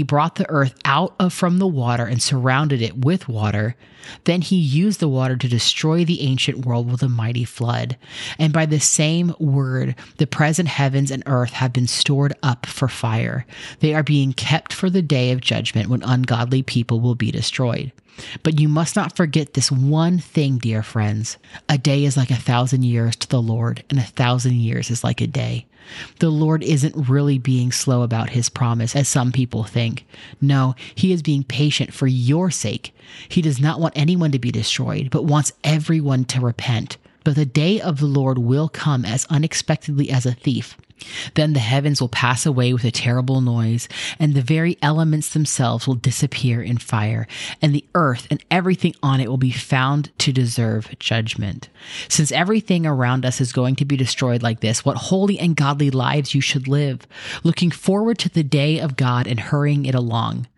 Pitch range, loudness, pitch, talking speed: 125-155 Hz, -19 LUFS, 135 Hz, 195 wpm